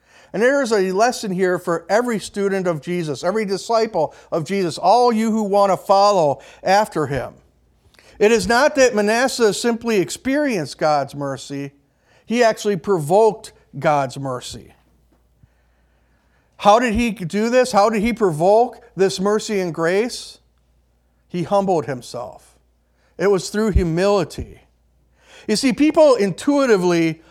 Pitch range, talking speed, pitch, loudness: 150-220 Hz, 135 wpm, 195 Hz, -18 LUFS